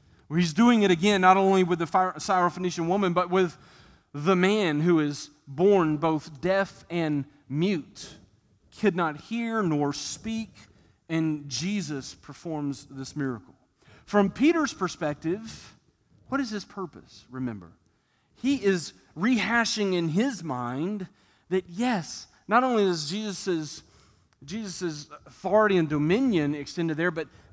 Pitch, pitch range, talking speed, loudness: 175 Hz, 145-195 Hz, 125 wpm, -26 LUFS